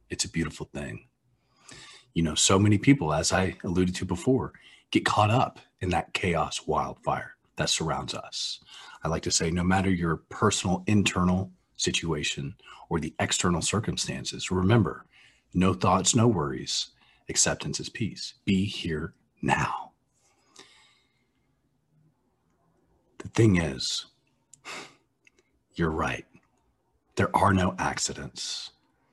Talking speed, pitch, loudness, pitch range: 120 wpm, 95 Hz, -27 LUFS, 90-125 Hz